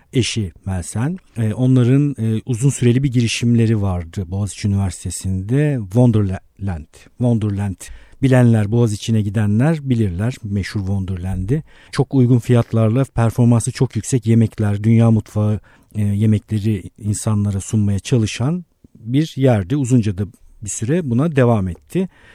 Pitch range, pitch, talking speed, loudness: 100-125 Hz, 110 Hz, 105 wpm, -18 LUFS